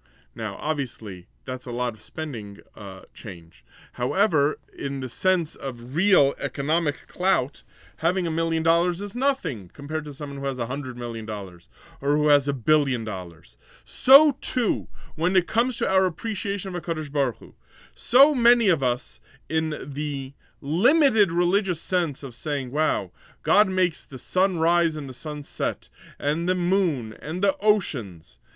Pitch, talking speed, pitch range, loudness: 155 Hz, 160 wpm, 130-185 Hz, -24 LUFS